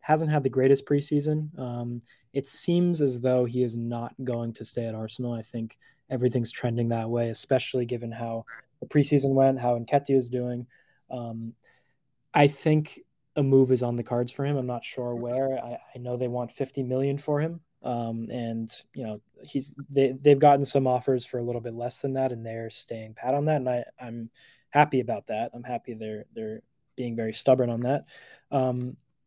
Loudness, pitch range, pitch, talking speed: -27 LUFS, 120-140 Hz, 125 Hz, 200 wpm